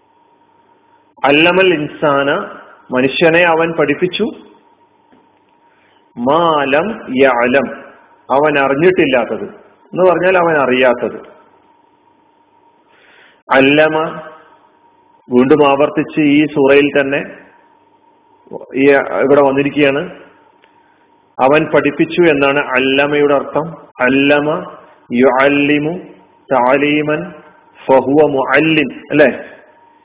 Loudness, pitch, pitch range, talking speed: -12 LUFS, 150 Hz, 140-185 Hz, 60 wpm